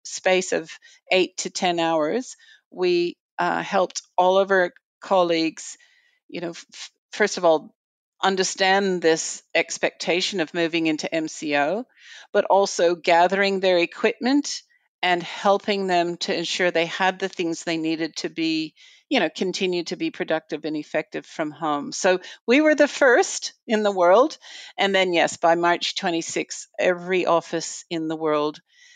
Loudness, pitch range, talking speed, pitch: -22 LUFS, 165-225 Hz, 150 wpm, 185 Hz